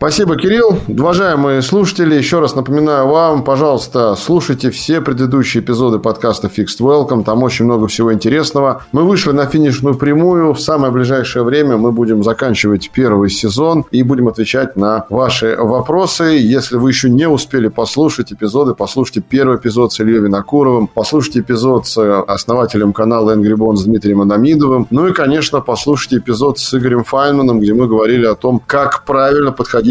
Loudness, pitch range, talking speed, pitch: -12 LUFS, 110-145 Hz, 160 wpm, 130 Hz